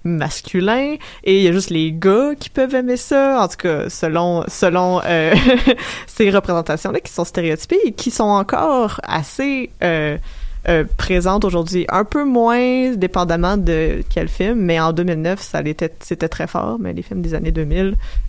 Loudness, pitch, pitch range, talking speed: -17 LUFS, 185 Hz, 165-235 Hz, 175 wpm